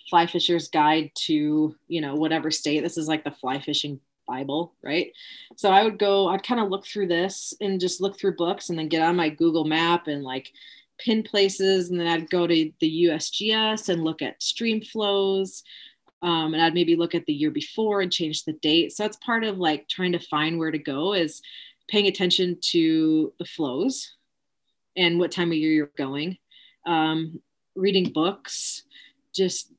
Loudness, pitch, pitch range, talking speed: -24 LUFS, 170 Hz, 160-195 Hz, 190 wpm